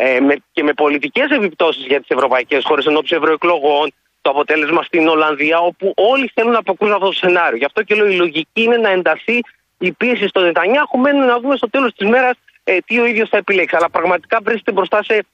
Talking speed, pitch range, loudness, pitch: 210 wpm, 160-230 Hz, -14 LUFS, 195 Hz